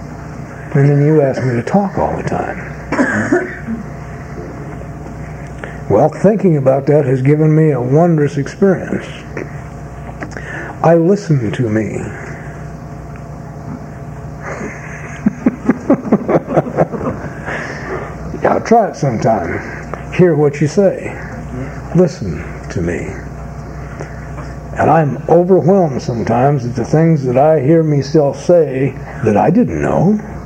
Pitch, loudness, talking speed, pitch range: 145 Hz, -14 LUFS, 100 wpm, 140-165 Hz